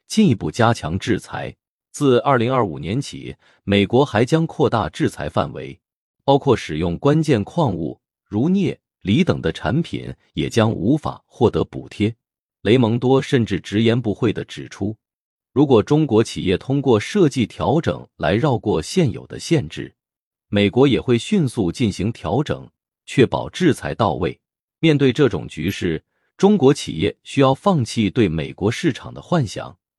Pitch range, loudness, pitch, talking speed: 105-145 Hz, -19 LUFS, 125 Hz, 235 characters per minute